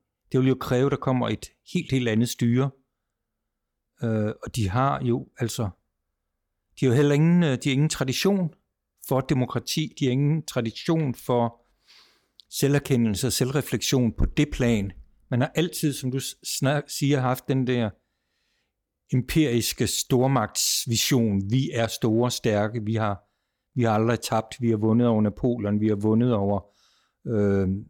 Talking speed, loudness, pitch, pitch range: 155 wpm, -24 LUFS, 120 Hz, 110-135 Hz